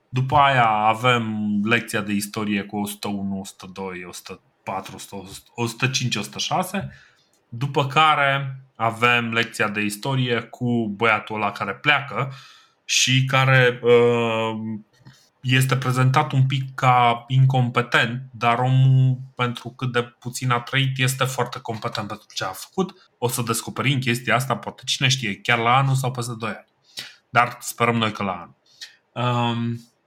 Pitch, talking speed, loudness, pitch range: 120 Hz, 135 wpm, -21 LUFS, 110-130 Hz